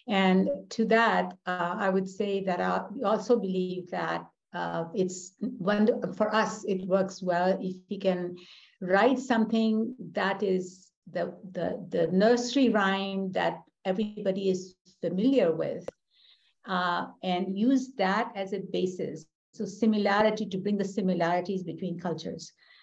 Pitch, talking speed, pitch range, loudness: 195 Hz, 135 wpm, 185-215 Hz, -28 LUFS